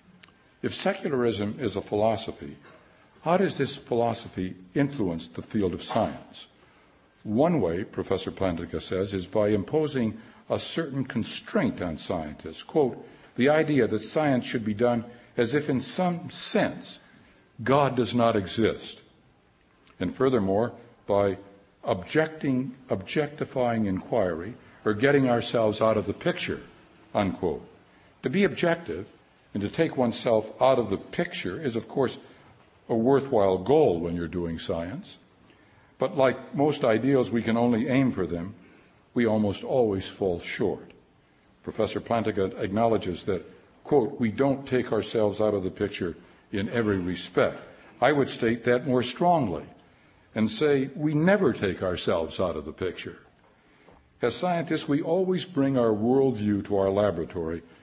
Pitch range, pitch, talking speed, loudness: 100-135 Hz, 115 Hz, 140 wpm, -27 LUFS